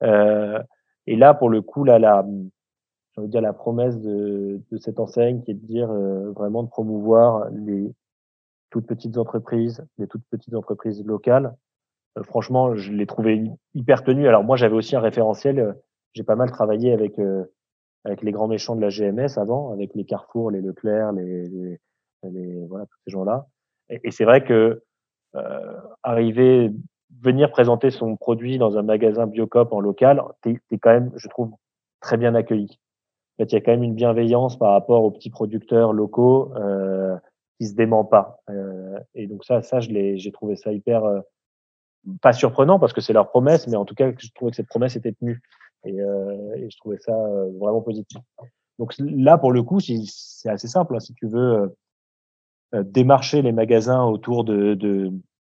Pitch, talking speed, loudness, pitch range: 110 Hz, 195 wpm, -20 LUFS, 100-120 Hz